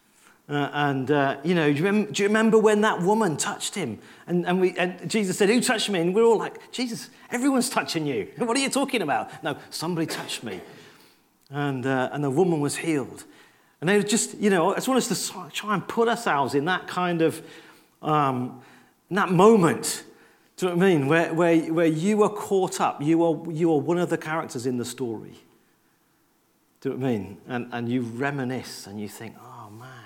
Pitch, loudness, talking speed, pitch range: 170 Hz, -24 LUFS, 215 wpm, 140-205 Hz